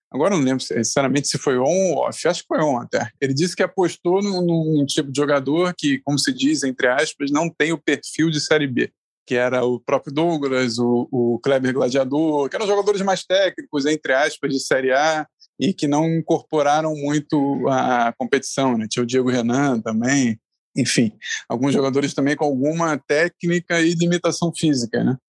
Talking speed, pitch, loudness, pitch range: 190 wpm, 145 Hz, -20 LUFS, 130-165 Hz